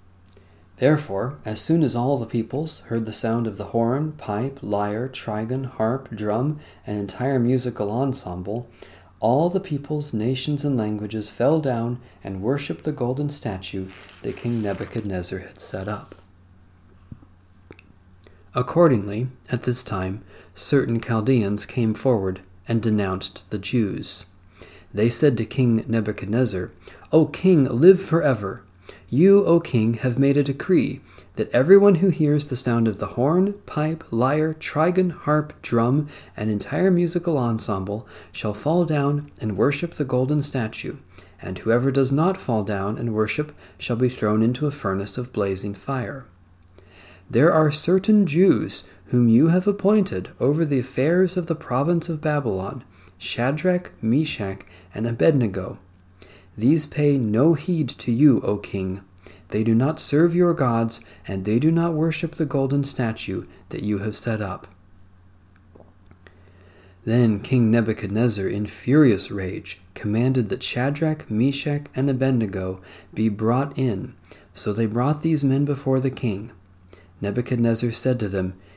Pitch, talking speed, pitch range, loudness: 115 Hz, 140 wpm, 100-145 Hz, -22 LUFS